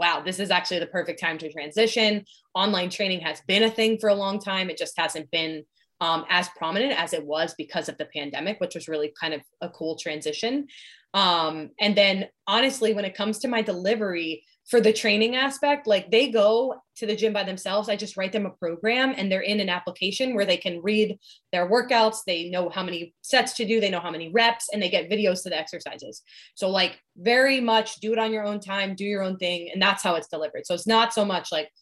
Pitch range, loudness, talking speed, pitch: 170-220 Hz, -24 LUFS, 235 wpm, 195 Hz